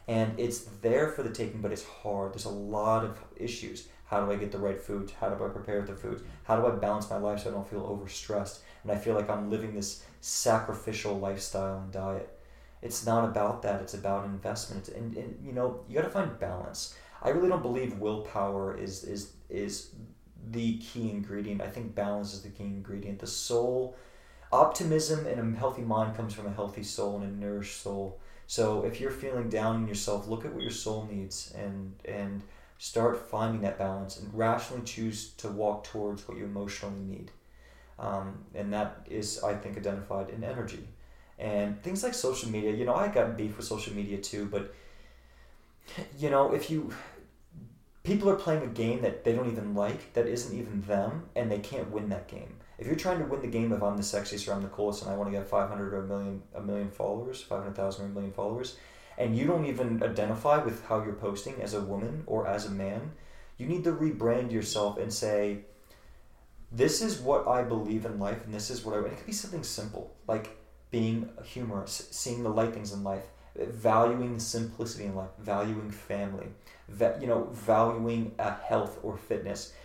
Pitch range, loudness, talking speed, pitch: 100-115 Hz, -32 LUFS, 205 wpm, 105 Hz